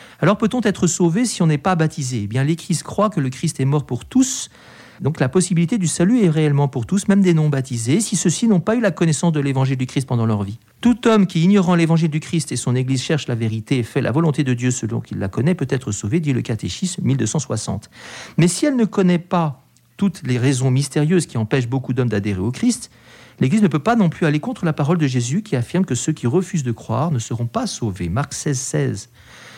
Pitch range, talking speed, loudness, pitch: 125-180 Hz, 245 wpm, -19 LUFS, 150 Hz